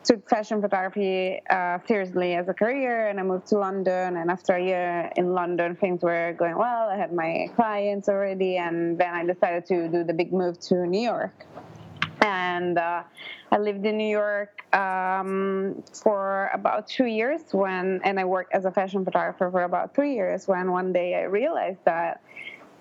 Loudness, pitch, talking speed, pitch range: -25 LUFS, 190 Hz, 185 wpm, 180-205 Hz